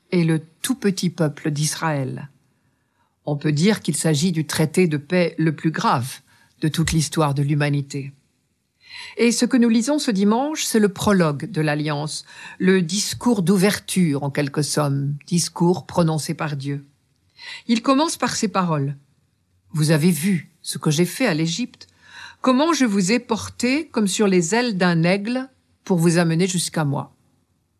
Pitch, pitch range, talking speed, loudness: 165 Hz, 150-205 Hz, 160 wpm, -20 LUFS